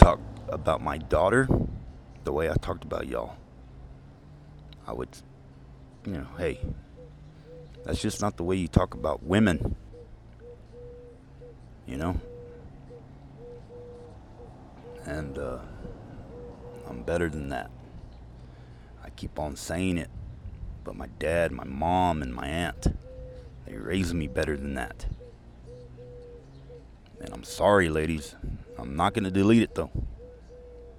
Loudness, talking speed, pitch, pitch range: -29 LUFS, 120 wpm, 85 Hz, 70-115 Hz